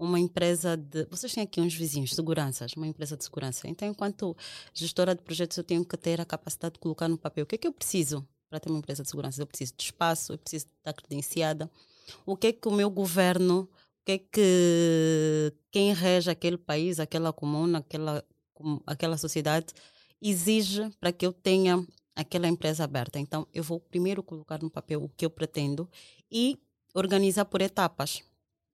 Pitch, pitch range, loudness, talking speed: 165 Hz, 155-180 Hz, -29 LUFS, 190 wpm